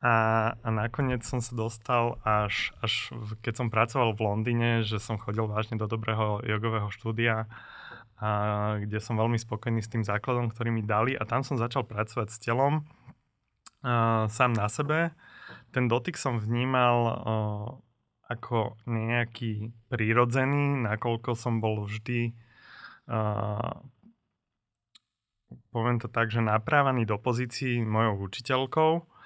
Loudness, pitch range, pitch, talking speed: -29 LUFS, 110-120 Hz, 115 Hz, 135 wpm